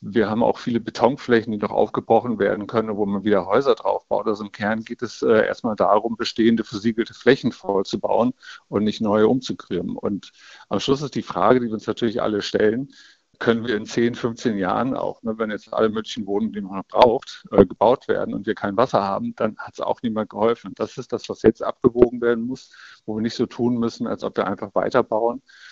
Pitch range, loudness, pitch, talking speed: 105-120 Hz, -22 LUFS, 115 Hz, 220 wpm